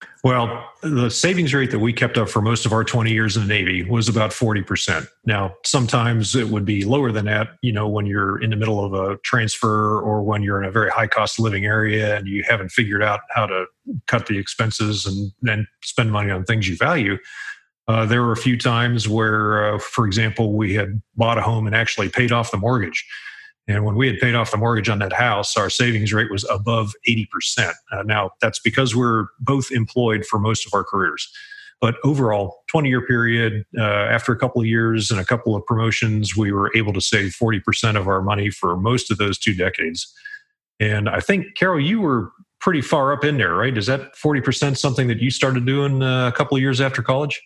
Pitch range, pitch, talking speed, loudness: 105-125 Hz, 115 Hz, 220 wpm, -19 LUFS